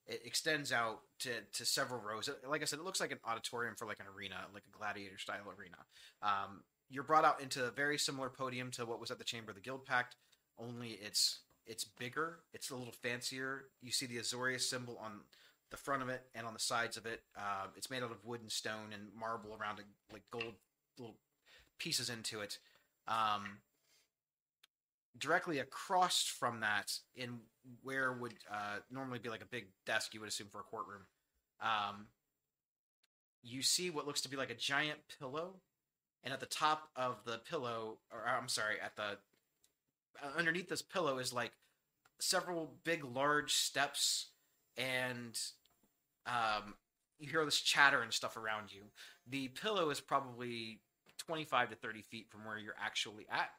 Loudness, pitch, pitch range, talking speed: -39 LUFS, 120 Hz, 110-135 Hz, 180 wpm